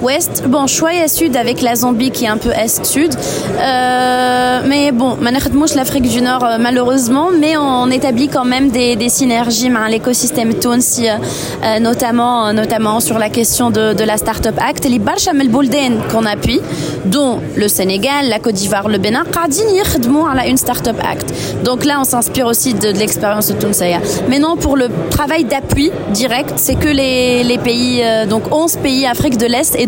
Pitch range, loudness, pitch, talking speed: 230-275 Hz, -13 LUFS, 250 Hz, 175 wpm